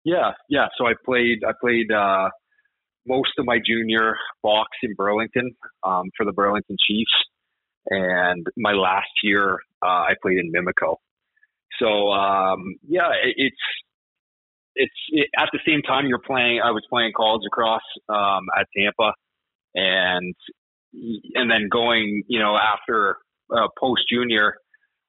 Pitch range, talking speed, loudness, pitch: 100-125 Hz, 145 wpm, -21 LUFS, 110 Hz